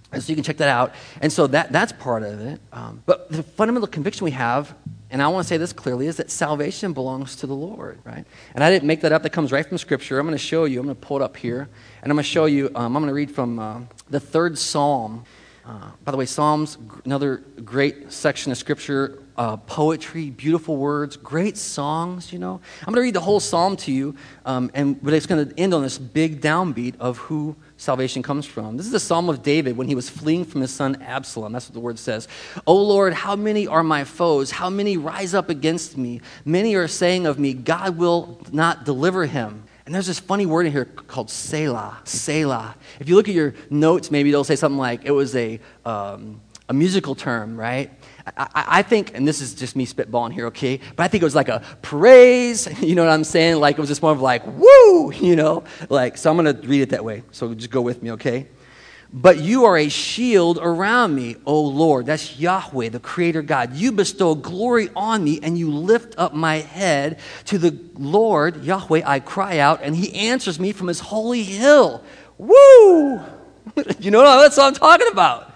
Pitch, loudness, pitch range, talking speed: 150 Hz, -18 LUFS, 135-175 Hz, 225 wpm